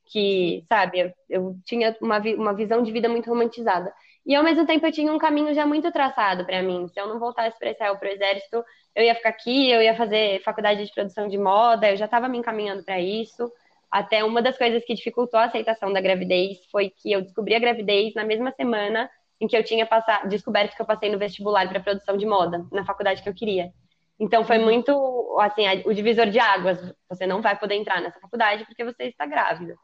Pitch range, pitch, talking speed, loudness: 195-235 Hz, 215 Hz, 225 wpm, -23 LUFS